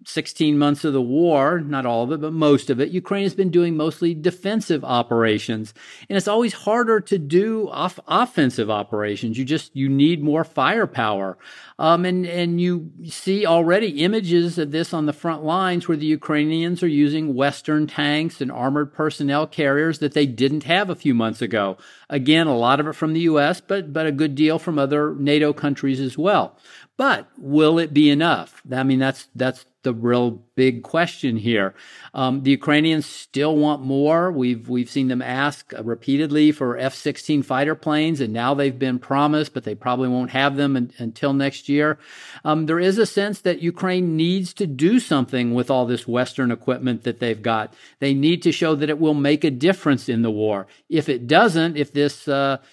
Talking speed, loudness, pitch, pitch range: 195 wpm, -20 LUFS, 145 Hz, 130-165 Hz